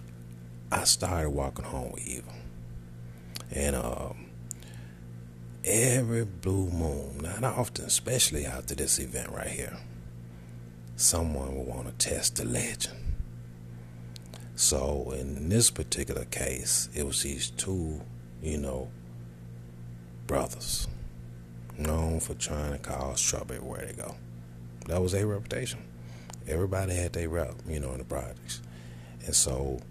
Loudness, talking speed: -30 LUFS, 125 wpm